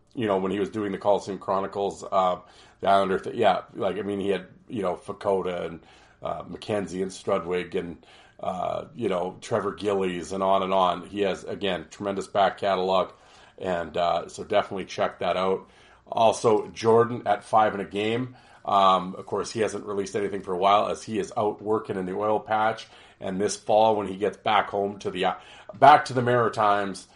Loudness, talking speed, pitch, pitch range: -25 LUFS, 200 wpm, 100 Hz, 95-105 Hz